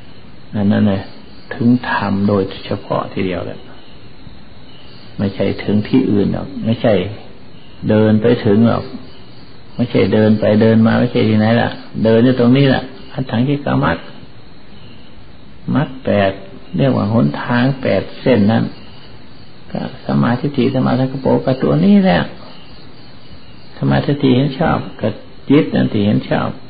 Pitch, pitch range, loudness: 115 Hz, 100-125 Hz, -15 LUFS